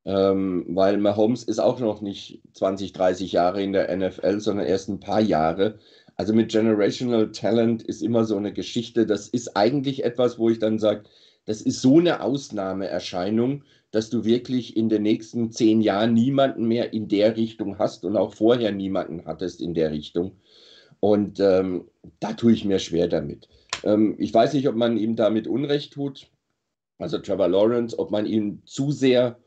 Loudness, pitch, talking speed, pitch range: -23 LUFS, 110 Hz, 180 wpm, 95-115 Hz